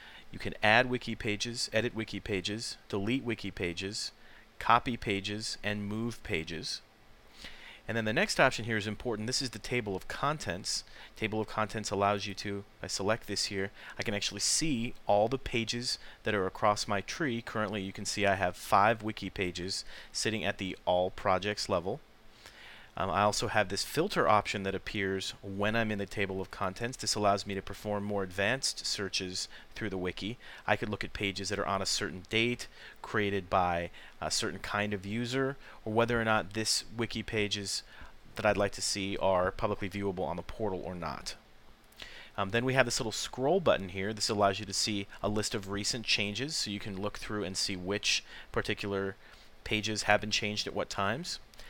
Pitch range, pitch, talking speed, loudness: 100-110 Hz, 105 Hz, 195 wpm, -32 LUFS